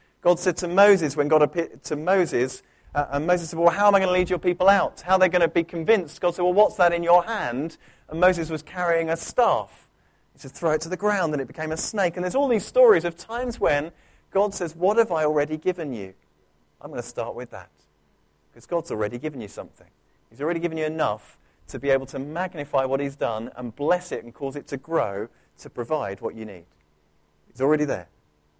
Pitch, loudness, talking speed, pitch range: 160 Hz, -23 LUFS, 235 wpm, 135-180 Hz